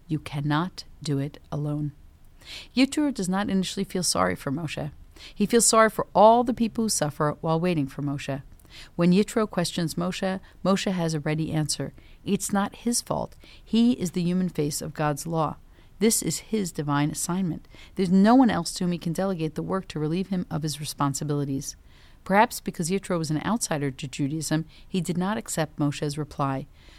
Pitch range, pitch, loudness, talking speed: 150-195 Hz, 165 Hz, -25 LUFS, 185 wpm